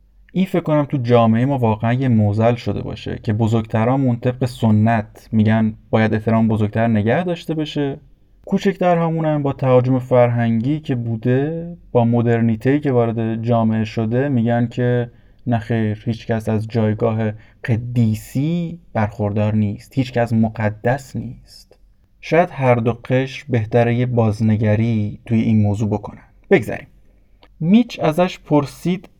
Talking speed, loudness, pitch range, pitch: 135 wpm, -18 LUFS, 110-135 Hz, 120 Hz